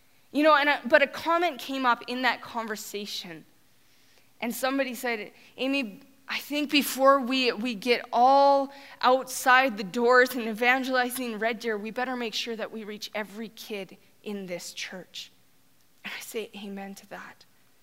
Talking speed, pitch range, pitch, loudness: 160 wpm, 215-265 Hz, 240 Hz, -26 LUFS